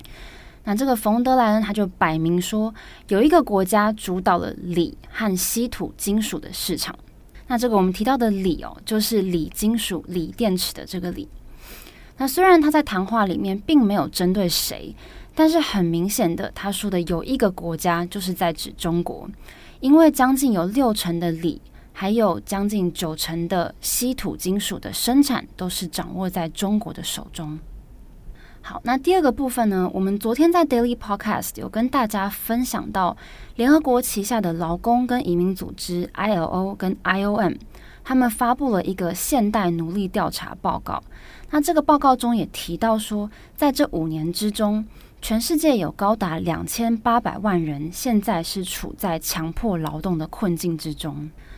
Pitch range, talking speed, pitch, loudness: 175-235 Hz, 265 characters per minute, 205 Hz, -22 LUFS